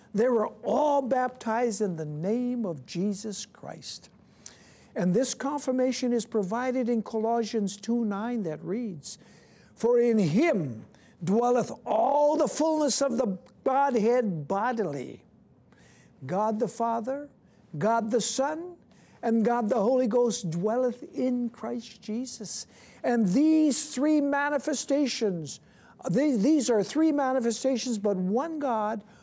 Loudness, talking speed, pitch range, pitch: -27 LUFS, 120 wpm, 215-265 Hz, 235 Hz